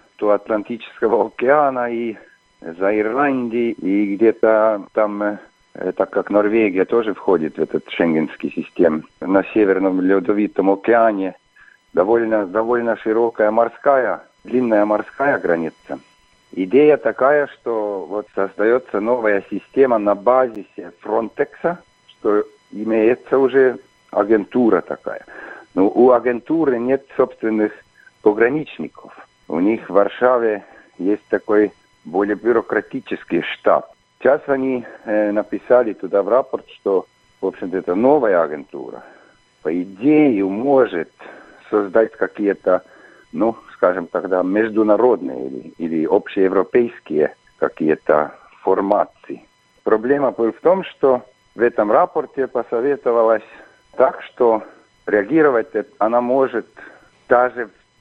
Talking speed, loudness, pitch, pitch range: 105 wpm, -18 LUFS, 110 Hz, 105-125 Hz